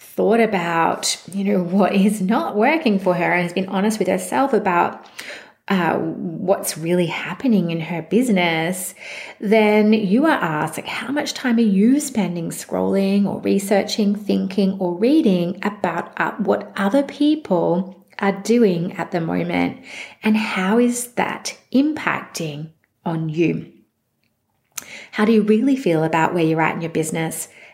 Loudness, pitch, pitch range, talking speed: -19 LUFS, 195 Hz, 175-220 Hz, 150 wpm